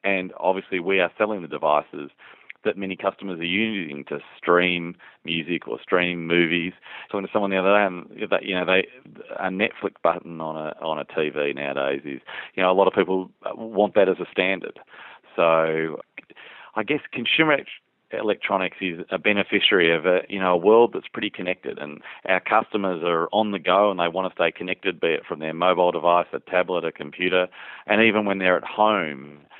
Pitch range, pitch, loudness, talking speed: 85-100 Hz, 90 Hz, -22 LUFS, 190 wpm